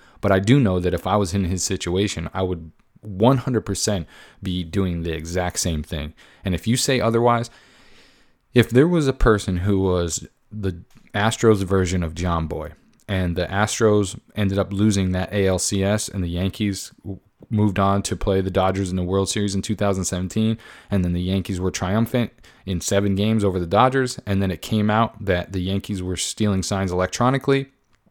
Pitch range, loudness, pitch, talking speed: 90-110 Hz, -21 LUFS, 100 Hz, 180 wpm